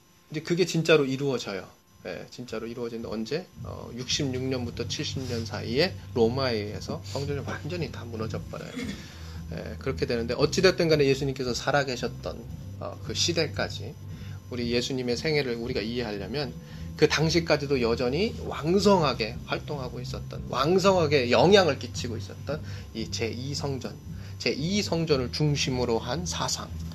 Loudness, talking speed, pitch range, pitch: -27 LUFS, 315 characters per minute, 100-145 Hz, 120 Hz